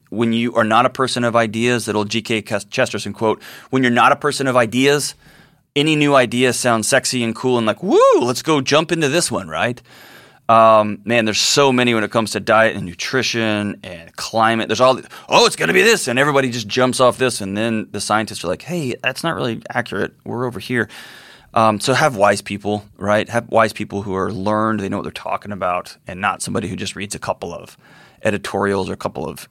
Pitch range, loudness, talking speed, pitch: 105-130 Hz, -17 LUFS, 225 wpm, 115 Hz